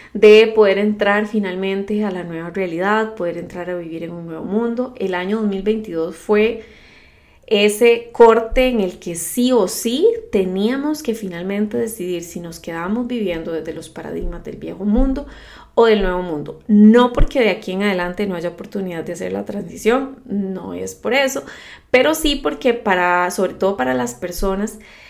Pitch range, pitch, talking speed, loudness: 175-230 Hz, 205 Hz, 170 wpm, -18 LUFS